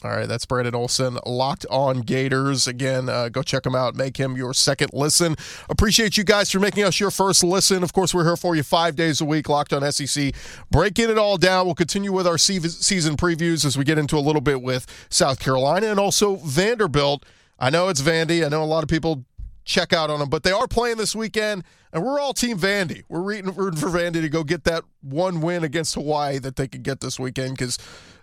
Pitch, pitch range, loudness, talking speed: 160 Hz, 135-185 Hz, -21 LUFS, 230 wpm